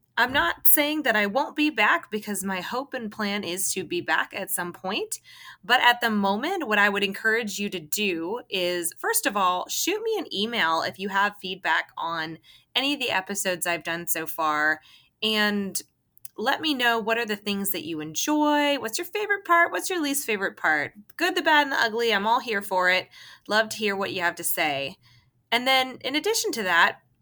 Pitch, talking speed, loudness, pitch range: 210 Hz, 215 wpm, -24 LUFS, 180-265 Hz